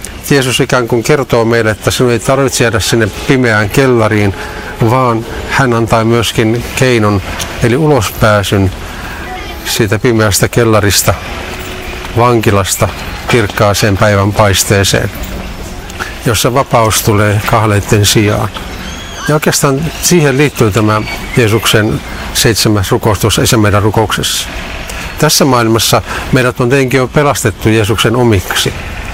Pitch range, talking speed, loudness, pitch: 100-125 Hz, 105 wpm, -10 LUFS, 110 Hz